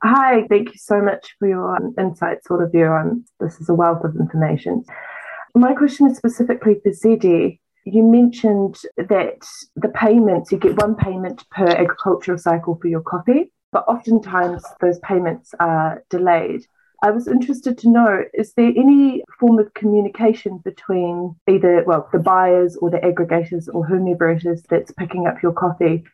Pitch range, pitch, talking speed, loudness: 175-230 Hz, 190 Hz, 160 wpm, -17 LUFS